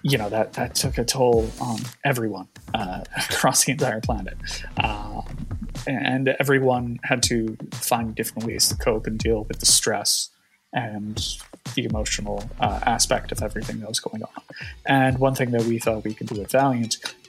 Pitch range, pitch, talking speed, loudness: 110-130 Hz, 115 Hz, 175 wpm, -23 LUFS